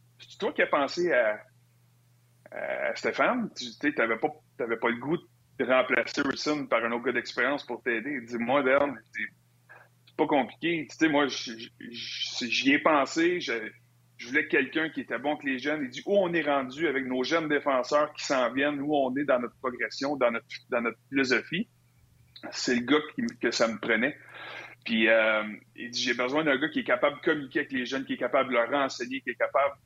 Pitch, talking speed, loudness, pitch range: 130 Hz, 215 wpm, -28 LUFS, 120-150 Hz